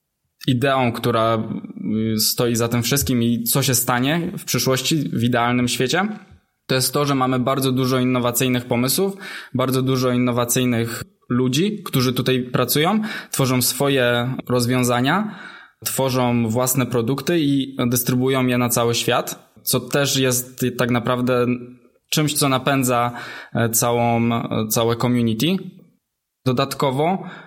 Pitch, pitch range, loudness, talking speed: 130 Hz, 120-140 Hz, -19 LUFS, 120 wpm